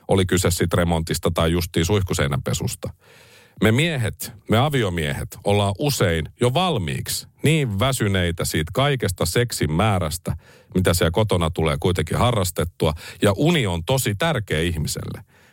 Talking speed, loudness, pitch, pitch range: 130 wpm, -21 LUFS, 100 Hz, 85-120 Hz